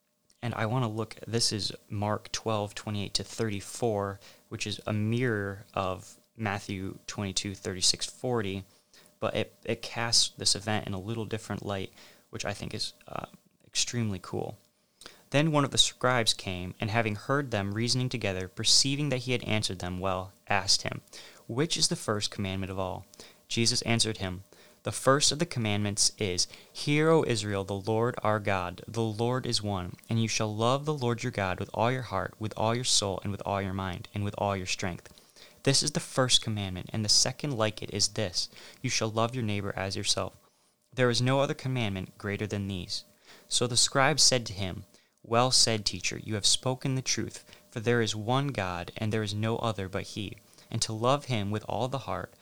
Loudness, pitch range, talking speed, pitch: -29 LUFS, 100-120 Hz, 205 wpm, 110 Hz